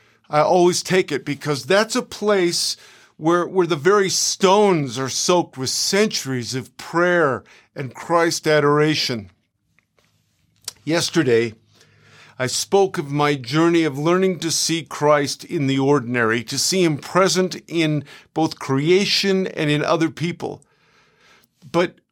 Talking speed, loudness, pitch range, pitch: 130 wpm, -19 LUFS, 135-175 Hz, 160 Hz